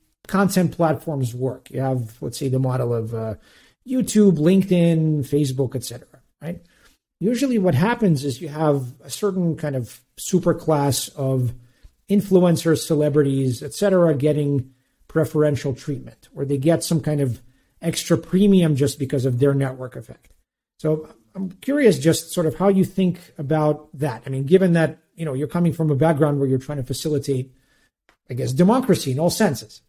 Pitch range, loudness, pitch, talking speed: 135-175 Hz, -21 LUFS, 150 Hz, 165 wpm